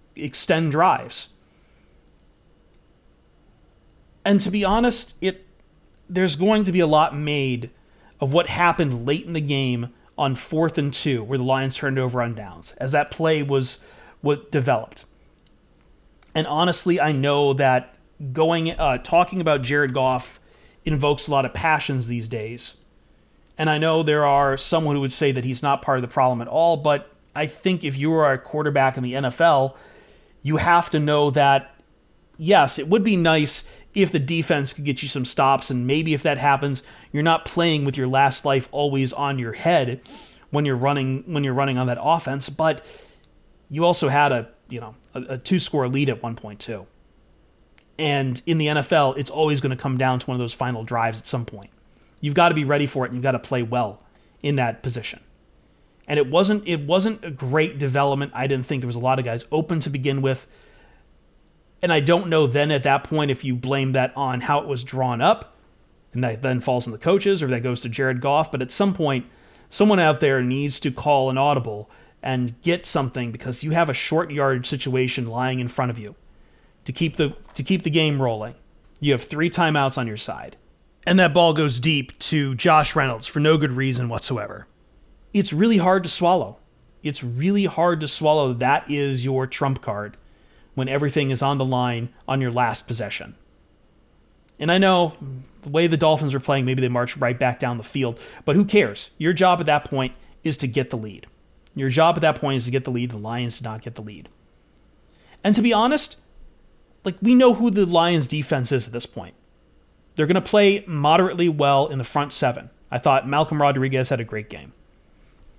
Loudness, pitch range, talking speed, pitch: -21 LUFS, 125-155 Hz, 200 wpm, 140 Hz